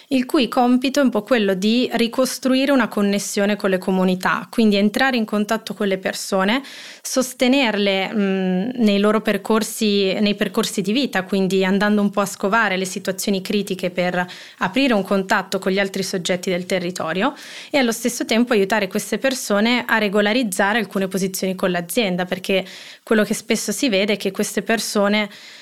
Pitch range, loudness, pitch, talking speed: 195-230 Hz, -19 LUFS, 210 Hz, 170 wpm